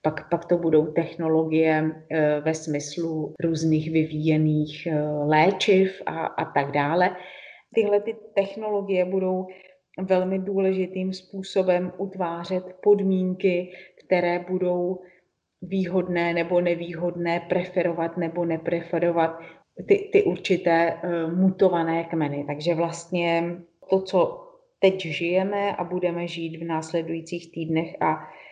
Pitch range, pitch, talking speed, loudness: 165-185 Hz, 175 Hz, 105 wpm, -24 LUFS